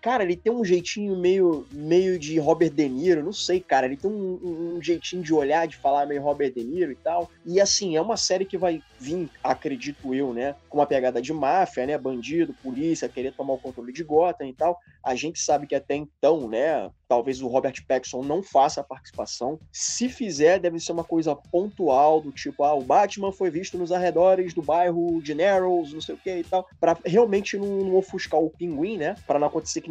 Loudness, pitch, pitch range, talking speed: -24 LUFS, 170 Hz, 145-185 Hz, 220 wpm